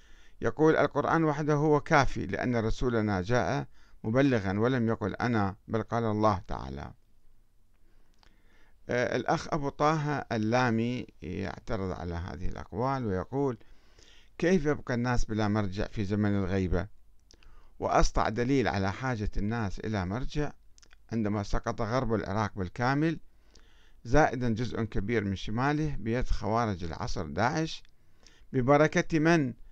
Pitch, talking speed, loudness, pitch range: 115 Hz, 115 wpm, -30 LUFS, 100-130 Hz